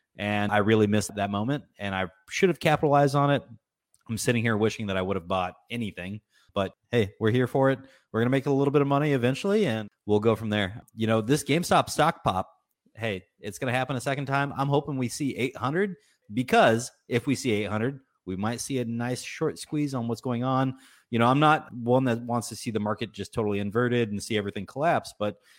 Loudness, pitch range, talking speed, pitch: -26 LUFS, 105-135 Hz, 230 wpm, 120 Hz